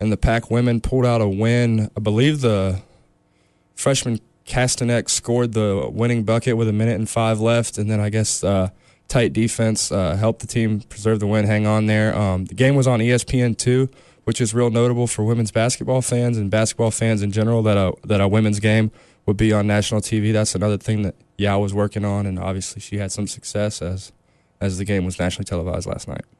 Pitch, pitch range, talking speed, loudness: 110 Hz, 100-115 Hz, 215 wpm, -20 LUFS